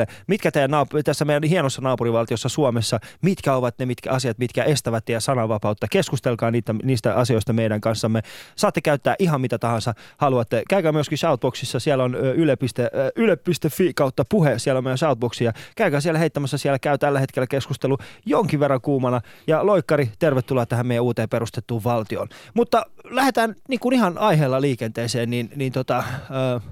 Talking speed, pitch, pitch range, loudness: 155 wpm, 130 Hz, 120-150 Hz, -21 LUFS